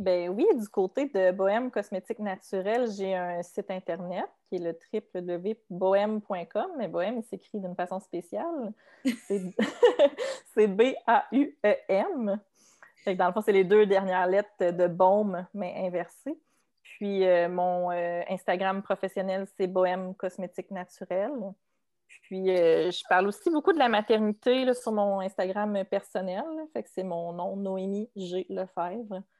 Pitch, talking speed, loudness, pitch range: 195 Hz, 145 wpm, -28 LUFS, 185-220 Hz